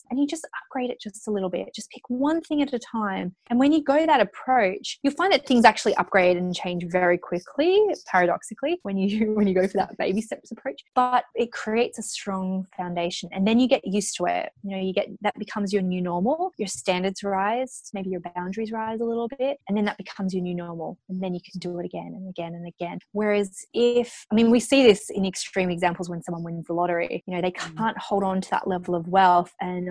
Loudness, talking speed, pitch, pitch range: -24 LUFS, 240 wpm, 200 Hz, 180-240 Hz